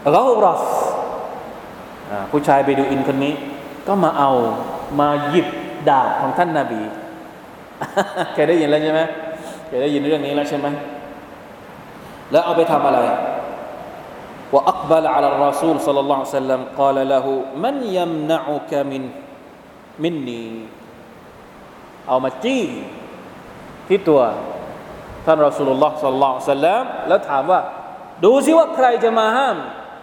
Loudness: -18 LUFS